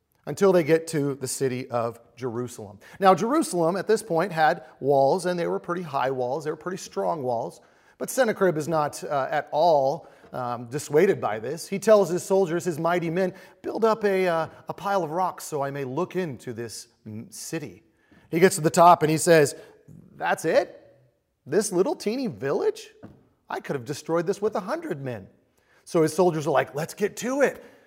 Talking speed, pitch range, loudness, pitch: 195 wpm, 140-195 Hz, -24 LUFS, 170 Hz